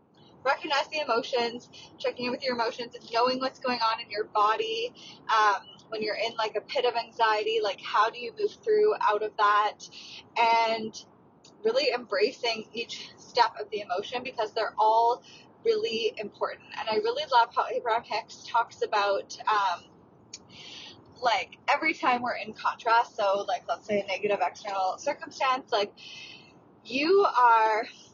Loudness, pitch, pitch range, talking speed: -27 LUFS, 230 Hz, 215-270 Hz, 160 wpm